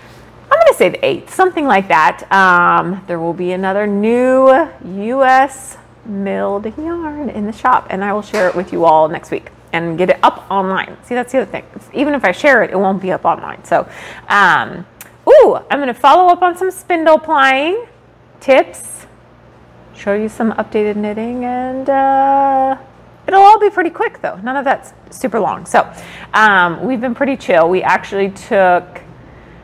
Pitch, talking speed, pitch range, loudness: 230 Hz, 180 wpm, 190-275 Hz, -13 LUFS